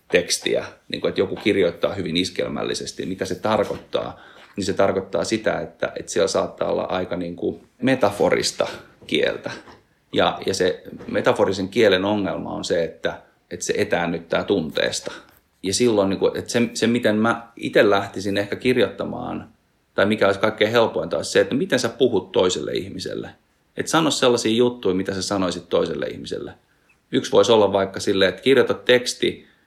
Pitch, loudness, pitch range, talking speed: 100 Hz, -21 LUFS, 95-120 Hz, 165 wpm